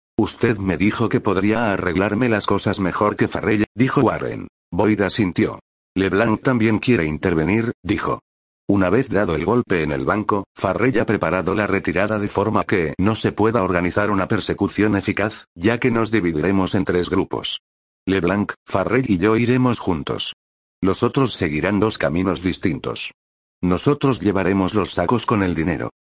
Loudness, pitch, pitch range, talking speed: -20 LUFS, 100 Hz, 90-110 Hz, 160 wpm